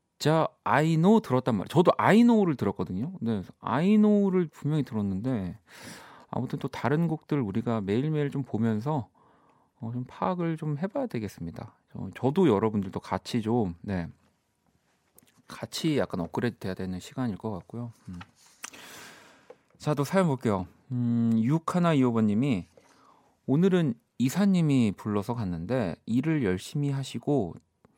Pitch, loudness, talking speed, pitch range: 120 Hz, -27 LUFS, 290 characters per minute, 105-155 Hz